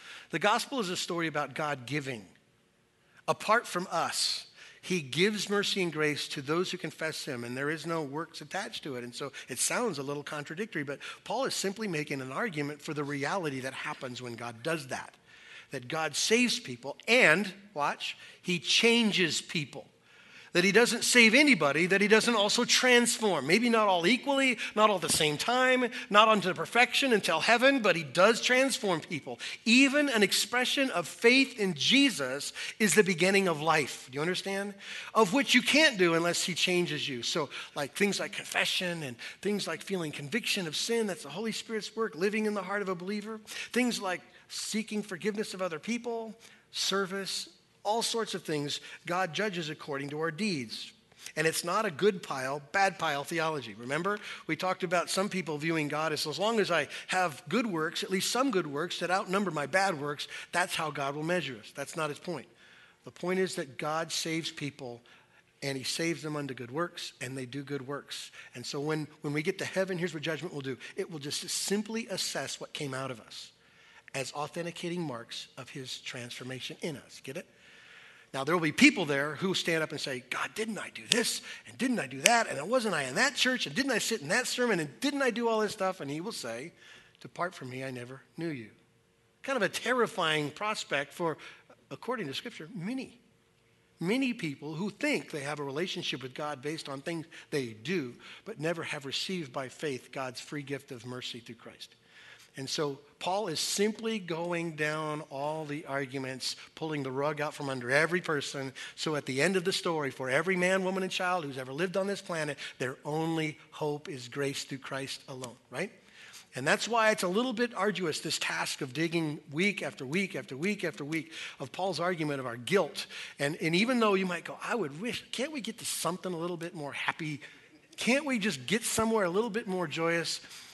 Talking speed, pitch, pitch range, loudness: 205 wpm, 170 Hz, 145-205 Hz, -30 LUFS